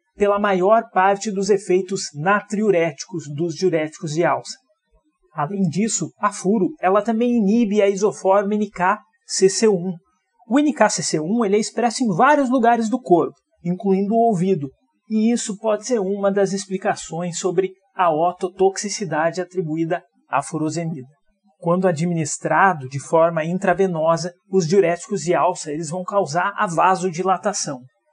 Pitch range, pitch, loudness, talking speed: 170-210 Hz, 190 Hz, -20 LUFS, 130 wpm